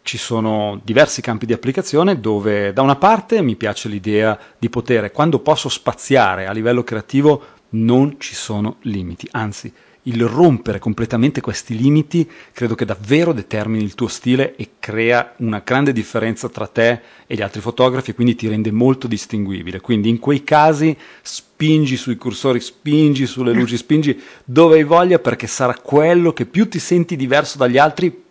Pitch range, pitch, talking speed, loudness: 110-145 Hz, 120 Hz, 165 wpm, -16 LUFS